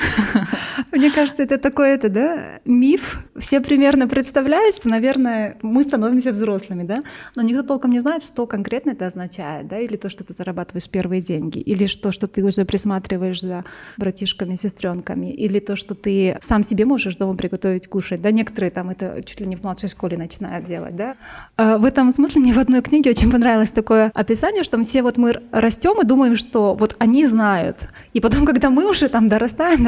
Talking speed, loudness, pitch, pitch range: 190 wpm, -18 LUFS, 225 Hz, 195-265 Hz